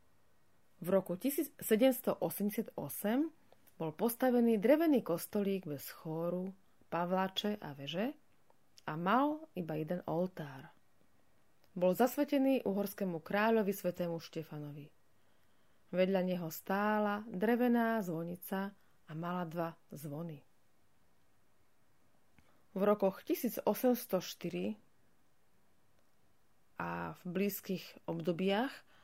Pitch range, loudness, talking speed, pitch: 155-215 Hz, -36 LUFS, 80 wpm, 185 Hz